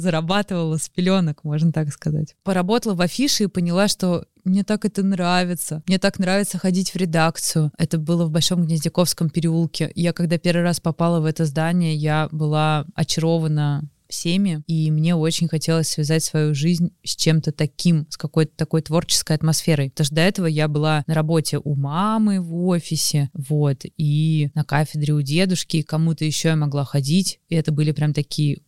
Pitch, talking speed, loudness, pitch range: 160 Hz, 175 wpm, -20 LUFS, 155-175 Hz